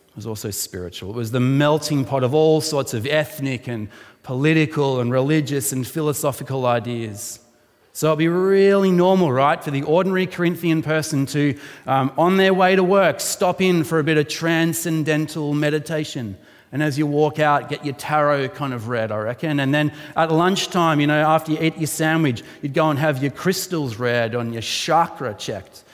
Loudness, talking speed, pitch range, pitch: -20 LUFS, 190 wpm, 130-160 Hz, 150 Hz